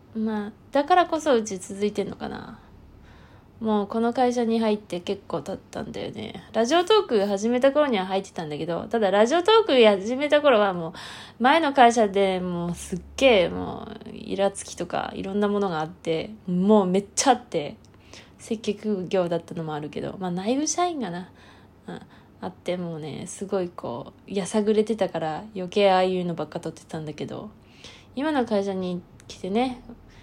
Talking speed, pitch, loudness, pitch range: 340 characters per minute, 205 Hz, -24 LUFS, 185-235 Hz